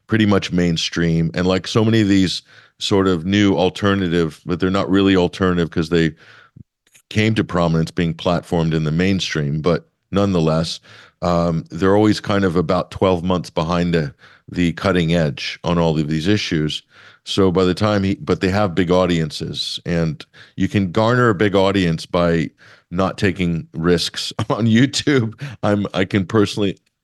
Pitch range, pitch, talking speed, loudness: 85-100 Hz, 95 Hz, 165 wpm, -18 LUFS